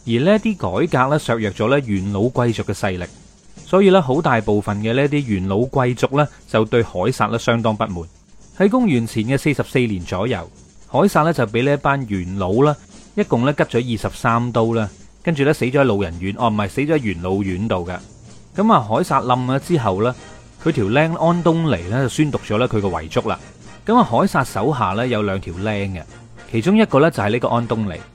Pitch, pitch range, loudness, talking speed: 120 Hz, 105-145 Hz, -18 LUFS, 305 characters per minute